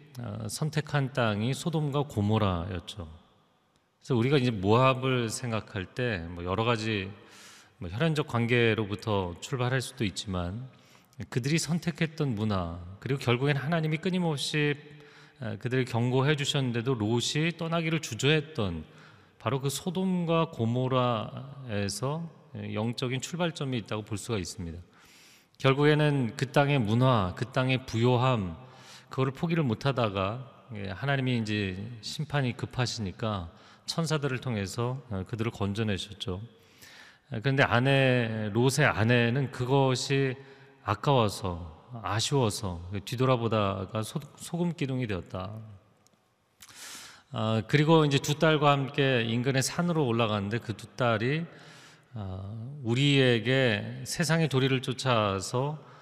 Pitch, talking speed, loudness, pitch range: 125 Hz, 265 characters per minute, -28 LUFS, 110-140 Hz